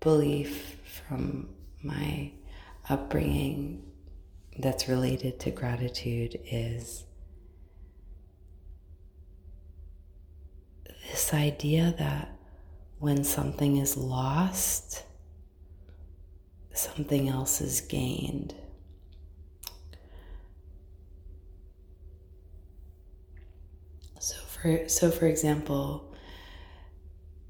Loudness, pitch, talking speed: -30 LUFS, 80 Hz, 55 wpm